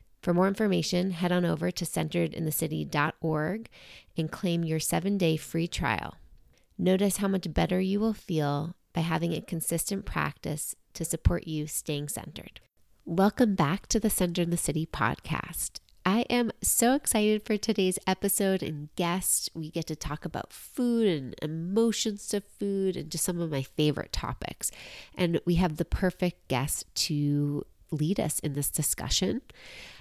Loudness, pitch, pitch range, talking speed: -29 LUFS, 175 Hz, 160-195 Hz, 160 wpm